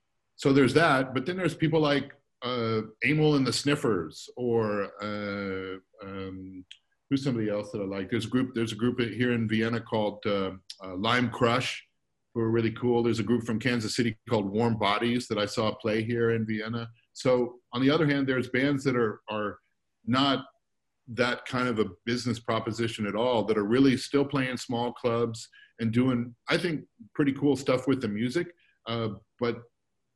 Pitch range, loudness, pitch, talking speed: 110-130 Hz, -28 LUFS, 120 Hz, 185 wpm